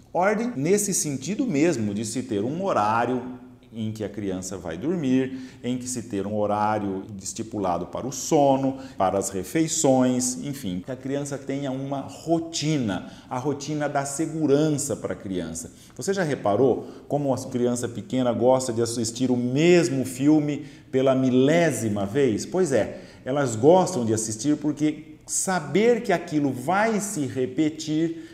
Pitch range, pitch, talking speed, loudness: 115-150 Hz, 130 Hz, 150 wpm, -24 LUFS